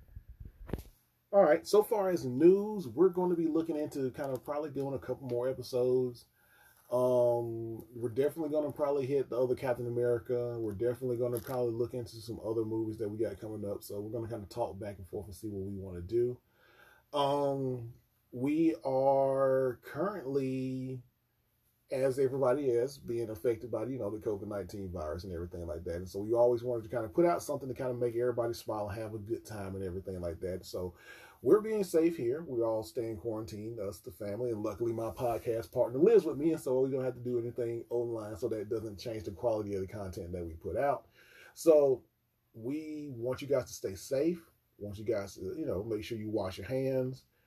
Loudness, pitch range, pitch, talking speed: -33 LUFS, 110-135 Hz, 120 Hz, 220 wpm